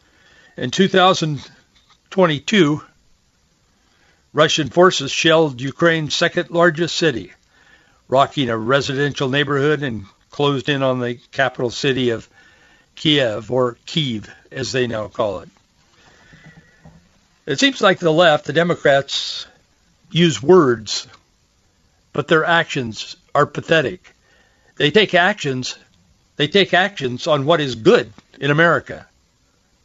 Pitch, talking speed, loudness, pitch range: 145 Hz, 110 wpm, -17 LUFS, 130-170 Hz